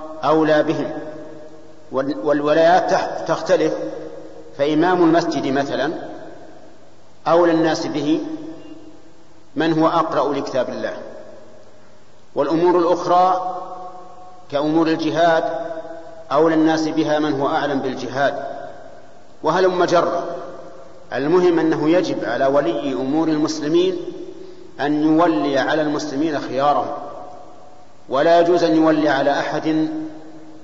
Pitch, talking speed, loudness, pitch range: 165 Hz, 90 wpm, -18 LUFS, 155-185 Hz